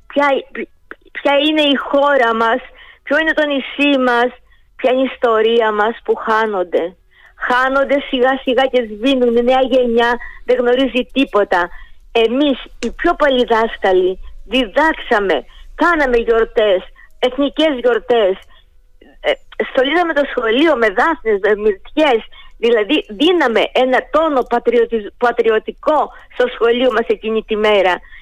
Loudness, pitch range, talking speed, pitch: -15 LUFS, 230-285 Hz, 115 wpm, 250 Hz